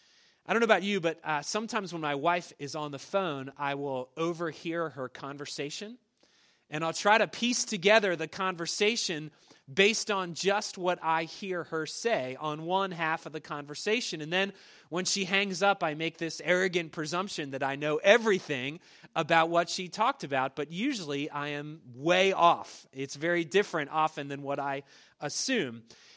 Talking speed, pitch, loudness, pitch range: 175 wpm, 165 Hz, -30 LUFS, 150-195 Hz